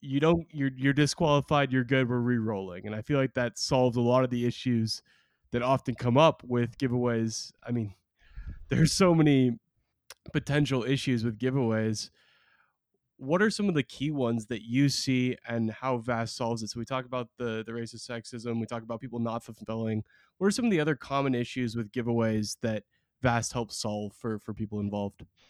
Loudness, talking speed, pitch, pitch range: -29 LUFS, 195 wpm, 120 Hz, 115-135 Hz